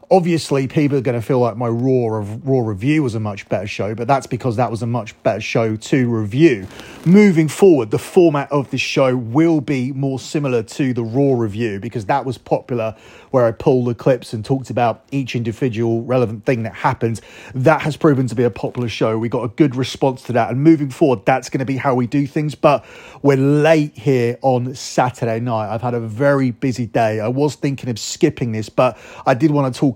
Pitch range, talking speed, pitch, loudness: 115-140 Hz, 220 wpm, 130 Hz, -17 LUFS